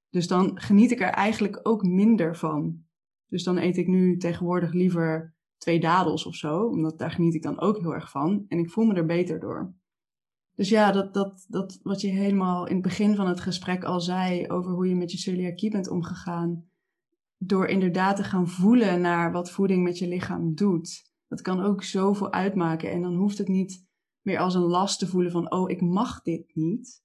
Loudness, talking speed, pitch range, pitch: -25 LUFS, 210 wpm, 170-195 Hz, 180 Hz